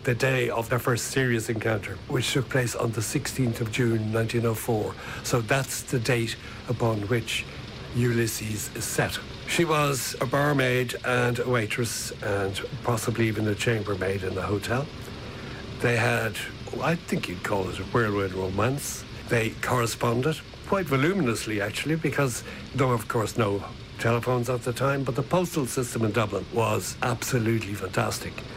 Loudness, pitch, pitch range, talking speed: -27 LUFS, 120 Hz, 110-130 Hz, 155 wpm